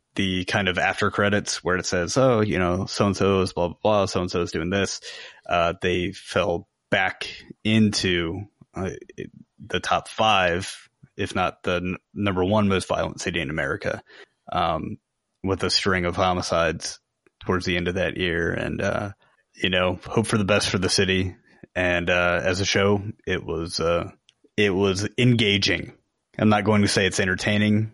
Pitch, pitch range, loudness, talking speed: 95 Hz, 90-105 Hz, -23 LUFS, 185 wpm